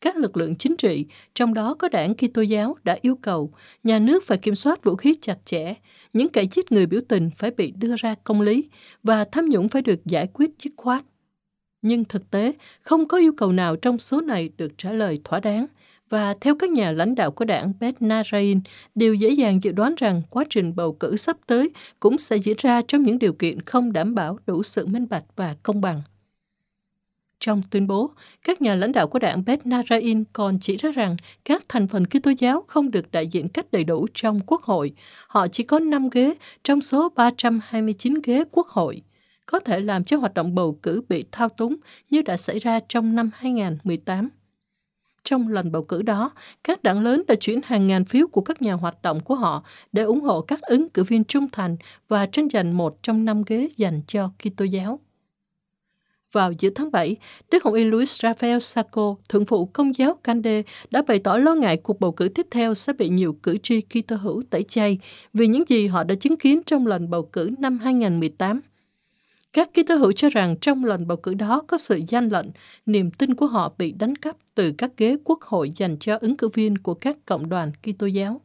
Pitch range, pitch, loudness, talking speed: 195-255 Hz, 220 Hz, -22 LUFS, 215 wpm